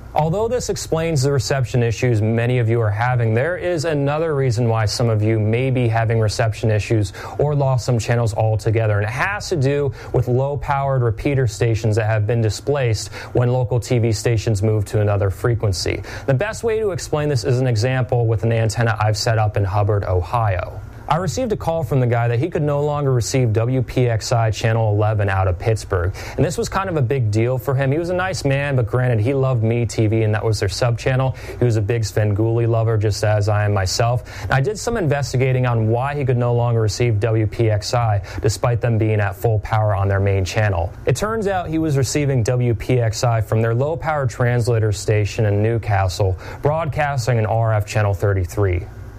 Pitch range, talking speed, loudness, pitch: 110-130 Hz, 205 wpm, -19 LUFS, 115 Hz